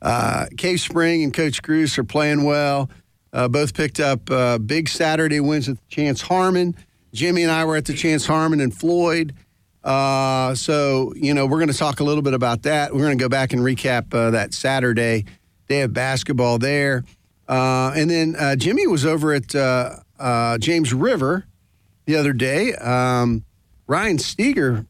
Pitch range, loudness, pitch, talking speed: 125-155 Hz, -19 LUFS, 135 Hz, 180 wpm